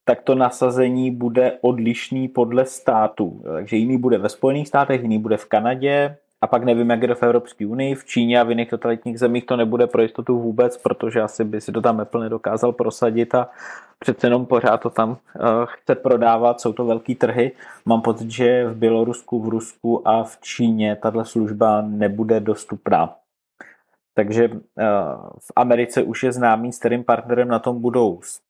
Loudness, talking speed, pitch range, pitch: -20 LUFS, 180 wpm, 115-125 Hz, 120 Hz